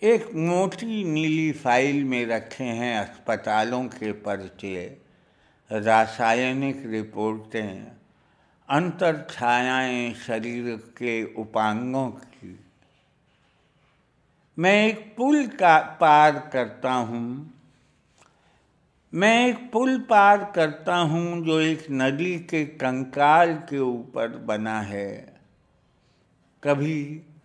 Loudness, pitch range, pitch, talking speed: -23 LUFS, 115-165 Hz, 135 Hz, 90 wpm